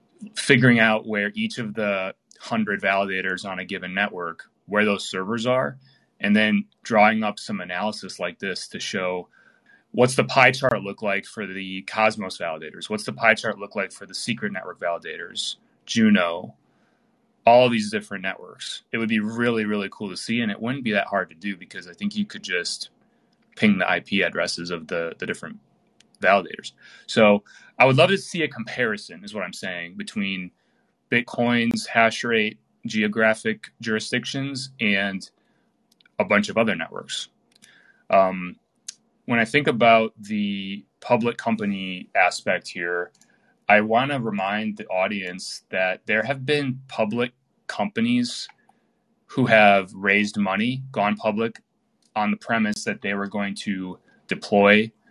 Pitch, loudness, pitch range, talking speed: 110 Hz, -23 LUFS, 100-130 Hz, 160 wpm